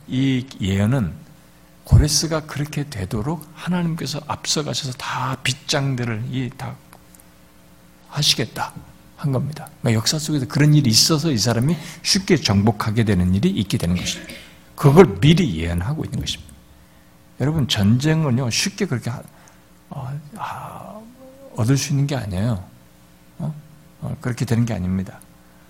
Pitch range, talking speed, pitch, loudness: 90-150 Hz, 280 characters per minute, 125 Hz, -20 LUFS